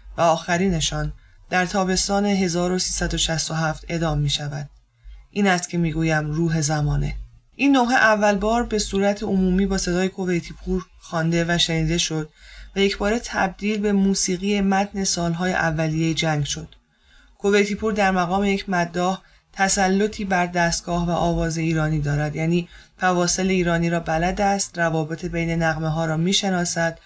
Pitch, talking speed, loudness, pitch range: 175 Hz, 145 wpm, -21 LUFS, 160-195 Hz